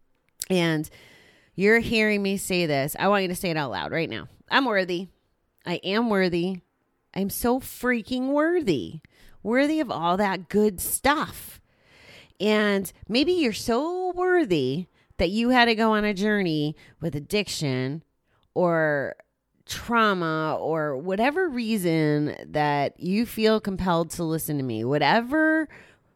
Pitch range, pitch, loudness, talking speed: 160-225 Hz, 190 Hz, -24 LUFS, 140 wpm